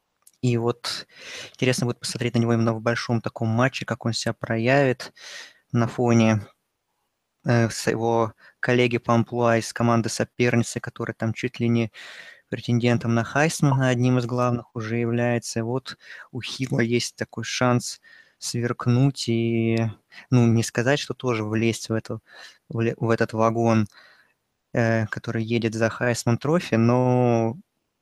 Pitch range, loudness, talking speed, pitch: 115-125 Hz, -23 LUFS, 140 wpm, 120 Hz